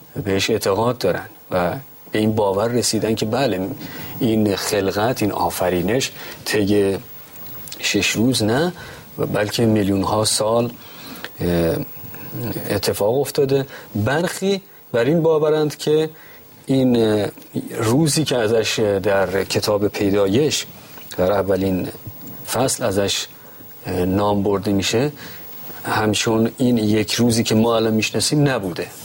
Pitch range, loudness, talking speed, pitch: 105-140 Hz, -19 LUFS, 110 wpm, 110 Hz